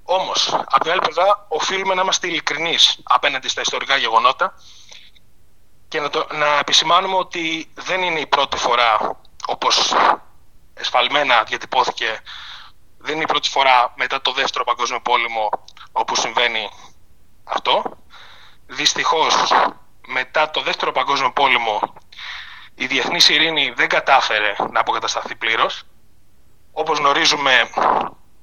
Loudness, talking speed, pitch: -17 LUFS, 120 wpm, 185 Hz